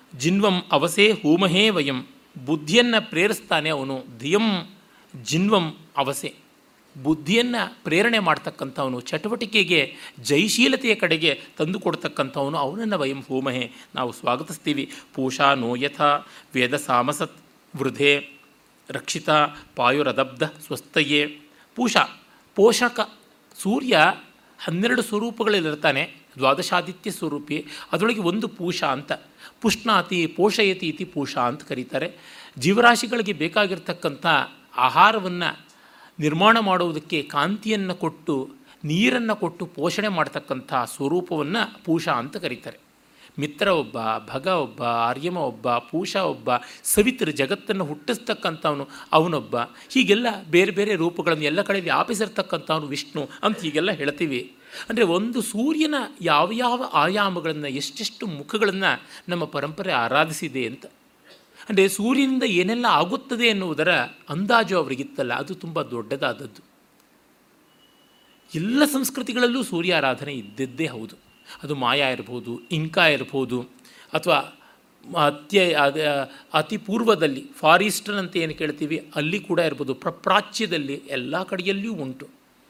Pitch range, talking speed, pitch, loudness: 145-210 Hz, 95 wpm, 170 Hz, -22 LUFS